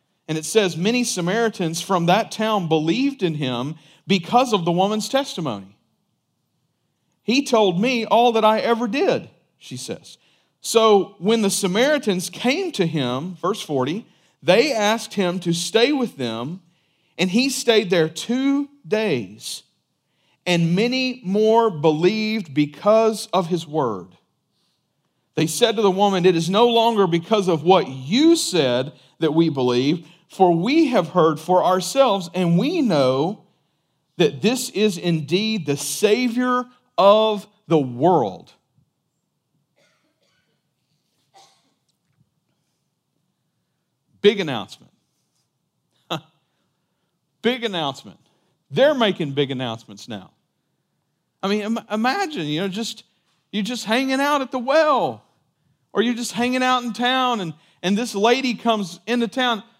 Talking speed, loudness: 130 wpm, -20 LUFS